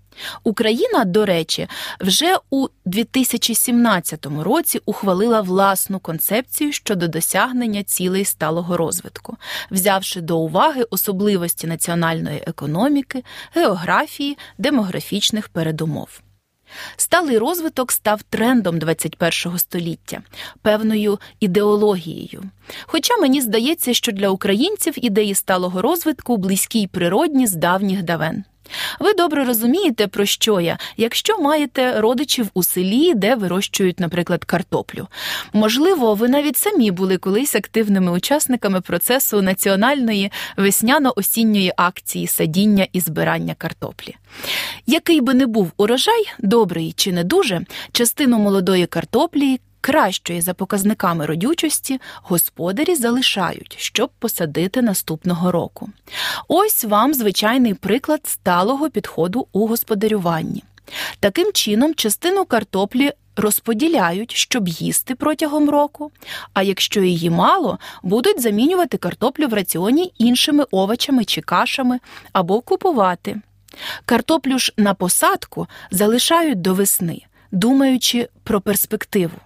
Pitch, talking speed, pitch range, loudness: 215 Hz, 105 wpm, 185-265 Hz, -18 LUFS